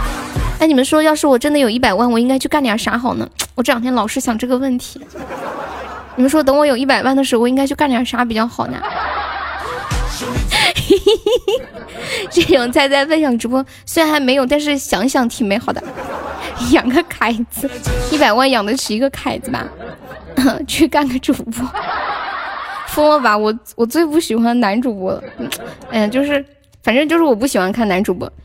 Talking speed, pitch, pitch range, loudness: 270 characters per minute, 265 Hz, 235-295 Hz, -16 LUFS